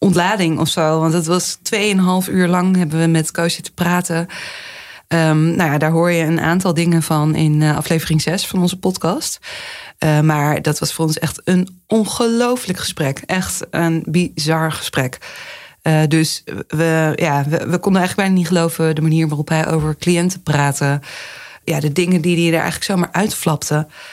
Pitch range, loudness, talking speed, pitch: 155-180 Hz, -16 LUFS, 180 wpm, 165 Hz